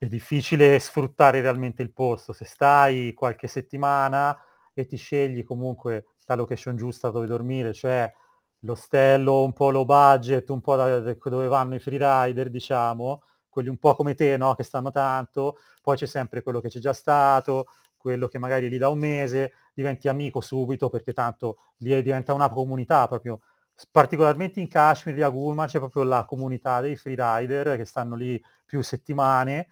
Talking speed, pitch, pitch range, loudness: 165 wpm, 130 Hz, 125-140 Hz, -24 LUFS